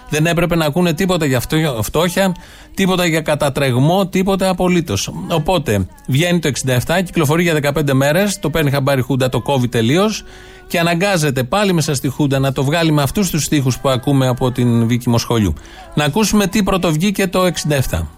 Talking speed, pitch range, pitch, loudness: 180 wpm, 130-180 Hz, 155 Hz, -16 LUFS